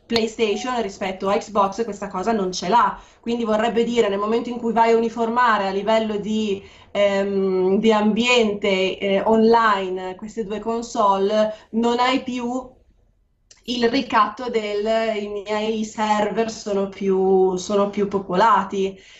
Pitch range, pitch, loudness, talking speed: 200-230 Hz, 215 Hz, -20 LUFS, 140 wpm